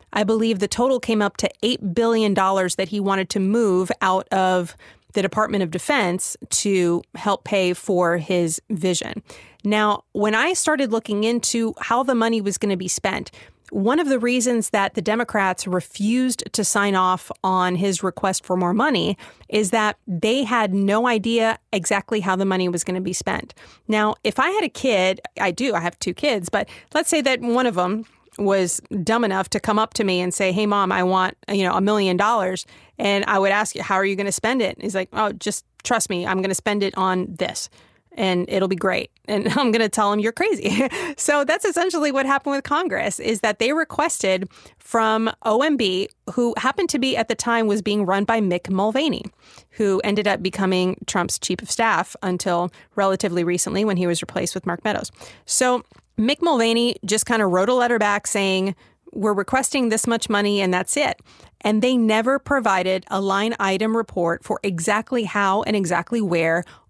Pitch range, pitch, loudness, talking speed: 190-230 Hz, 205 Hz, -21 LUFS, 200 wpm